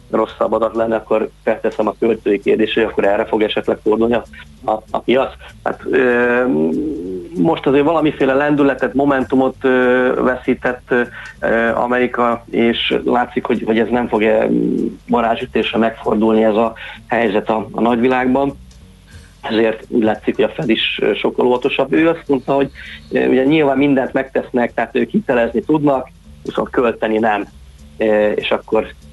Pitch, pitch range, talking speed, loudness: 120 Hz, 110-130 Hz, 140 wpm, -16 LUFS